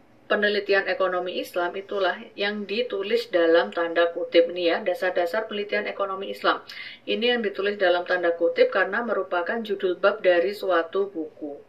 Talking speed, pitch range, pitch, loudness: 145 wpm, 175-205 Hz, 185 Hz, -24 LUFS